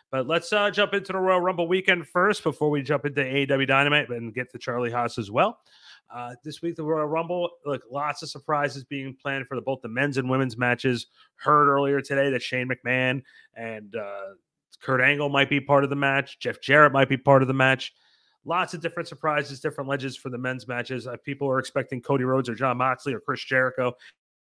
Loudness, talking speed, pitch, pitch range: -24 LUFS, 215 wpm, 140 Hz, 130-150 Hz